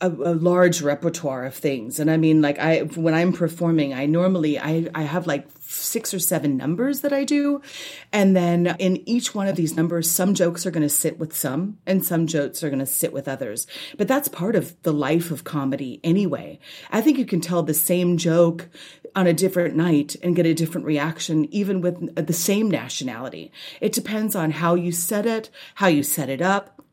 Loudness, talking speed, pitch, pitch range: -22 LUFS, 210 wpm, 170 Hz, 155-190 Hz